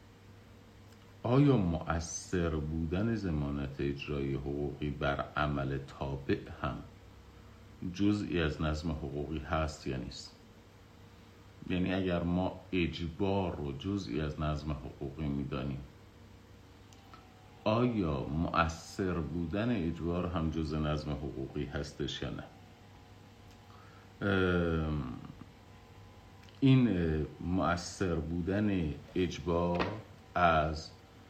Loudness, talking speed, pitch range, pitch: -34 LUFS, 80 wpm, 75-100 Hz, 90 Hz